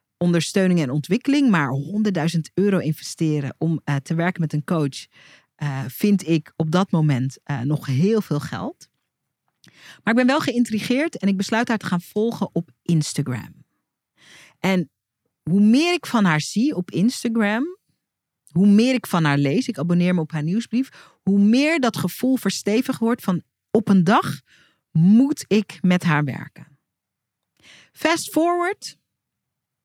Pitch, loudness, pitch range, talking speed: 185 Hz, -21 LUFS, 155-225 Hz, 155 wpm